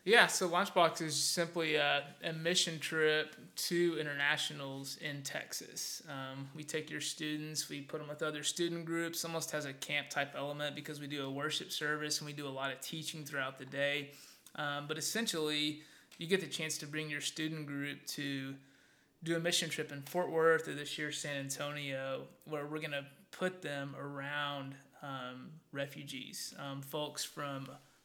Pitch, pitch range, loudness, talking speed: 150 Hz, 140-160 Hz, -37 LUFS, 180 wpm